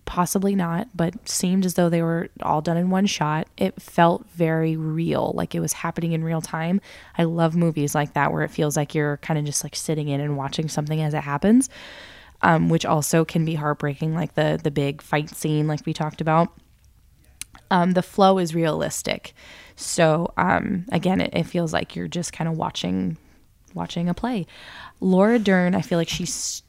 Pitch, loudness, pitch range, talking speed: 165 Hz, -23 LUFS, 150-175 Hz, 200 wpm